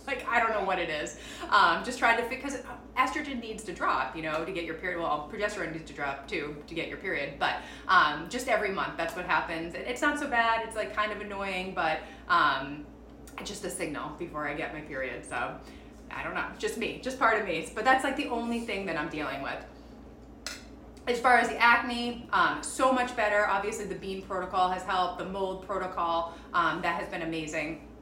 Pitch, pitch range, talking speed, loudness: 205 Hz, 170-240 Hz, 220 wpm, -29 LUFS